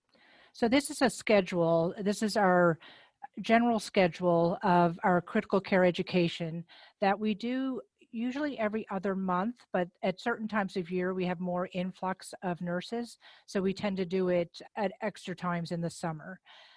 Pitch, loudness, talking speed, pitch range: 190 Hz, -31 LUFS, 165 wpm, 180-220 Hz